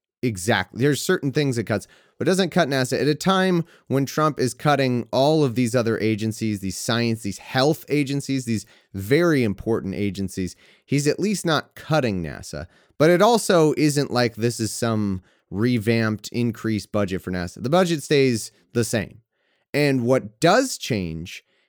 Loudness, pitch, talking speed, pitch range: -22 LUFS, 120 Hz, 165 wpm, 110-145 Hz